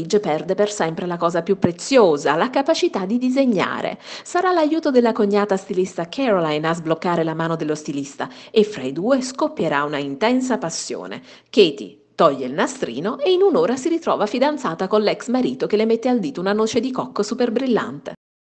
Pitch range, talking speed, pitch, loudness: 170-255 Hz, 180 wpm, 210 Hz, -20 LUFS